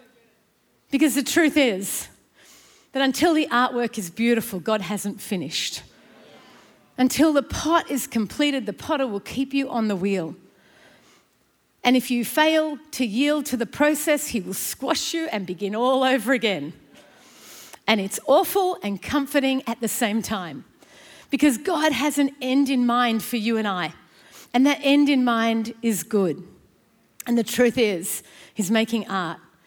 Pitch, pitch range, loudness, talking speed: 245 Hz, 215-280 Hz, -22 LUFS, 160 wpm